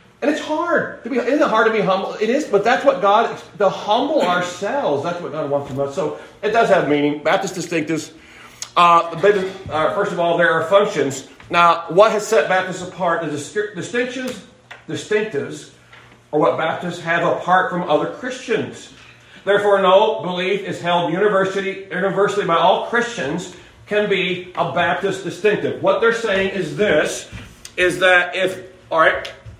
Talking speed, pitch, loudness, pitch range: 170 wpm, 185 Hz, -18 LUFS, 170-210 Hz